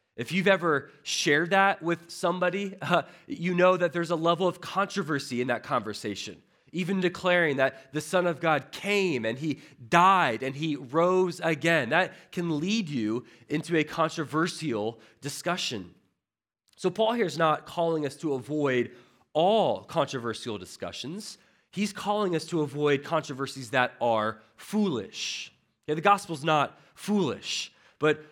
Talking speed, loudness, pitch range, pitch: 145 wpm, -27 LUFS, 135-180 Hz, 160 Hz